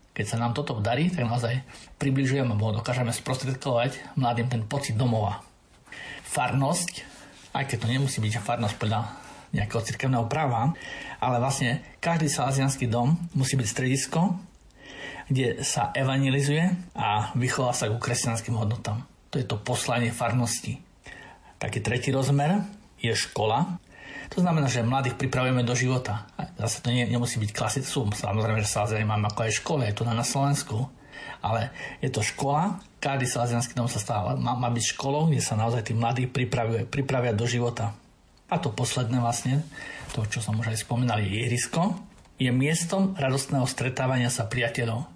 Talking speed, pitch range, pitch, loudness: 155 wpm, 115-140 Hz, 125 Hz, -27 LUFS